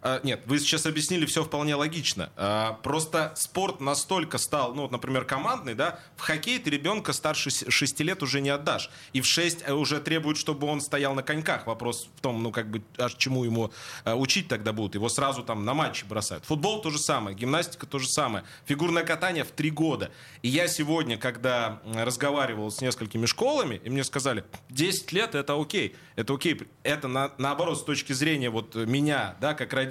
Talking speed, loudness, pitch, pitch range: 200 wpm, -28 LUFS, 140 Hz, 125-155 Hz